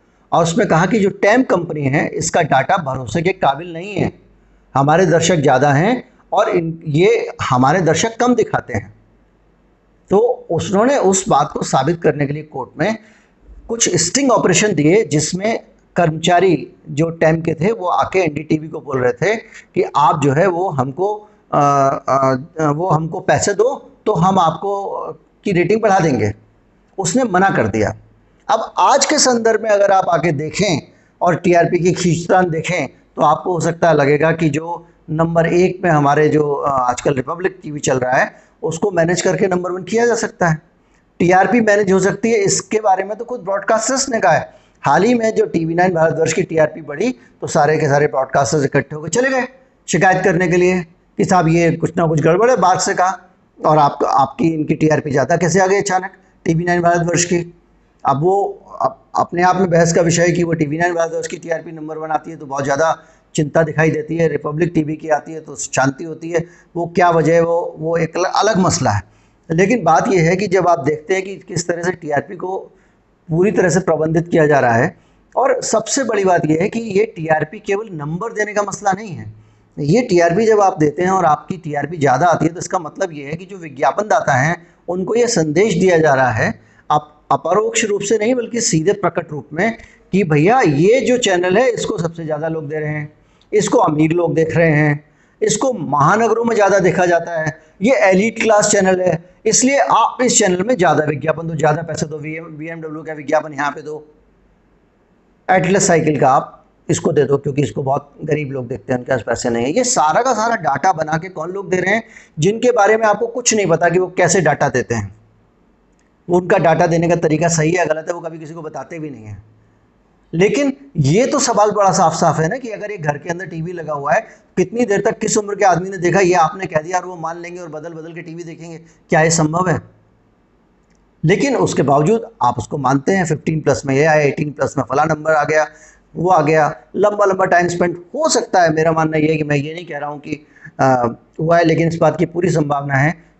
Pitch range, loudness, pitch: 155-195 Hz, -16 LUFS, 170 Hz